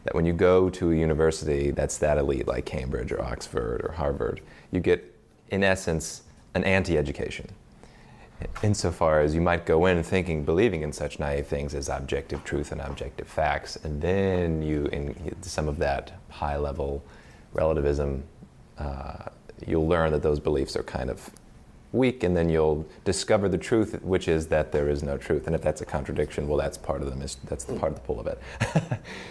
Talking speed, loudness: 185 wpm, -27 LUFS